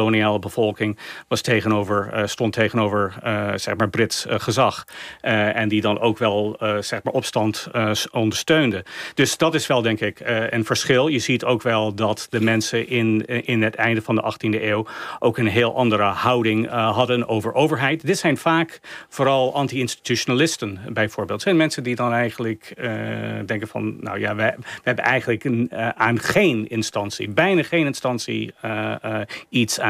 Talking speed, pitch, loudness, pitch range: 180 wpm, 115 Hz, -21 LUFS, 110-125 Hz